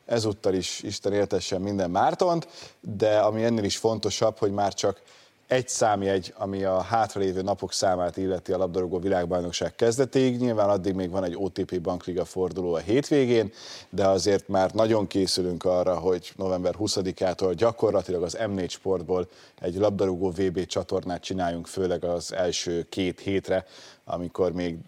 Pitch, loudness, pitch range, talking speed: 95 Hz, -26 LUFS, 90-105 Hz, 145 wpm